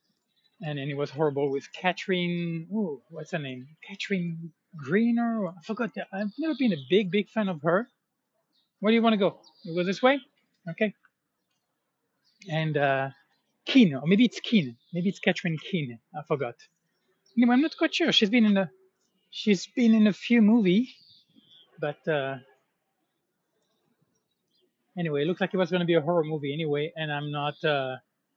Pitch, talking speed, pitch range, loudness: 185 Hz, 170 wpm, 155-220 Hz, -26 LUFS